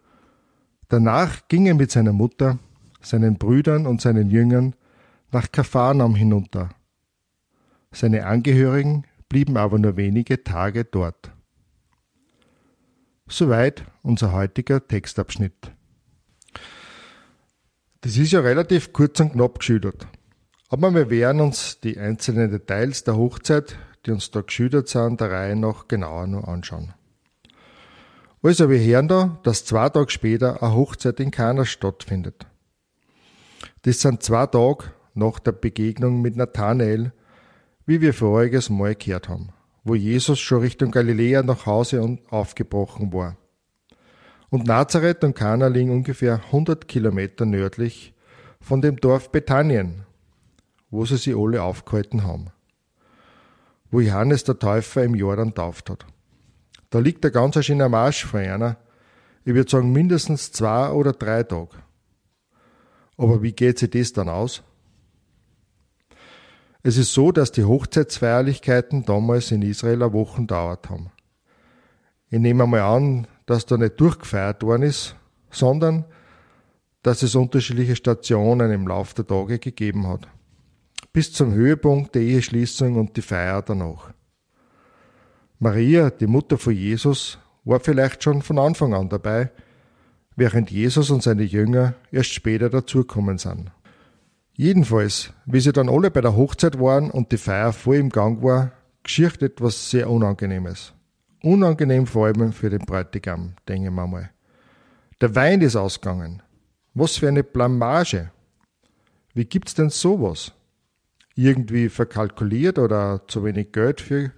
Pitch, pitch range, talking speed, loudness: 120 Hz, 105-130 Hz, 135 wpm, -20 LUFS